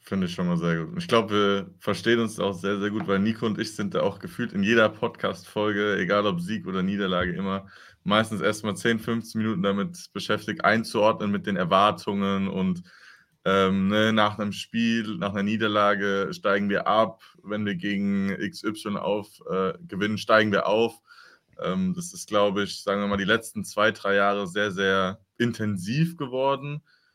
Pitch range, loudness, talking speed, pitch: 100-110 Hz, -25 LUFS, 180 wpm, 105 Hz